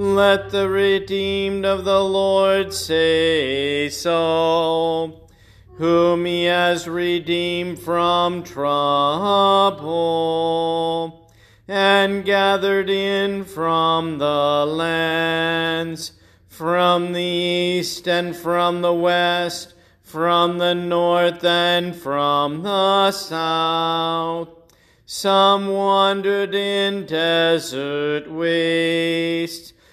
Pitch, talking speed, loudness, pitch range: 170 Hz, 80 wpm, -19 LUFS, 165-195 Hz